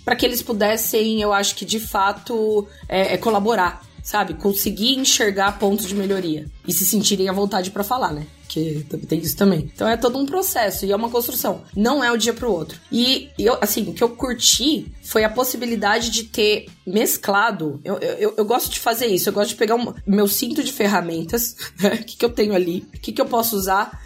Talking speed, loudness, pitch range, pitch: 220 wpm, -20 LUFS, 195-235 Hz, 210 Hz